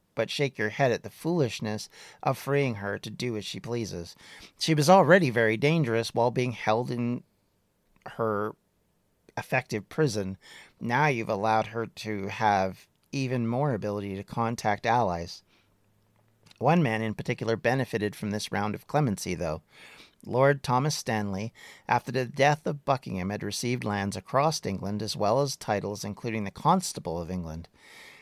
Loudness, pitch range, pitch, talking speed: -28 LUFS, 105-130 Hz, 115 Hz, 155 wpm